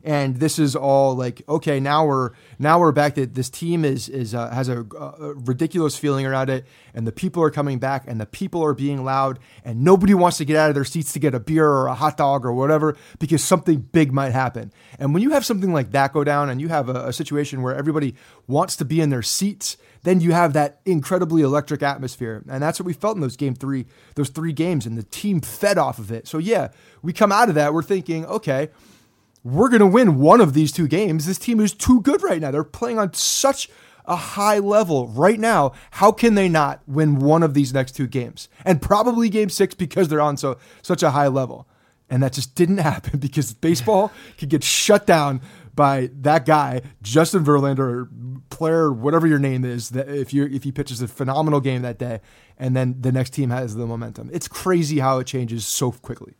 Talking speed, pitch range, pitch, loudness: 230 wpm, 130-165 Hz, 145 Hz, -20 LUFS